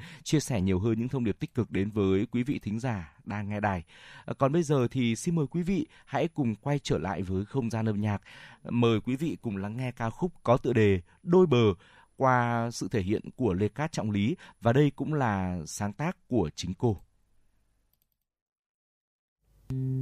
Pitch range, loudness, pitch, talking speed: 100-135 Hz, -29 LUFS, 115 Hz, 200 wpm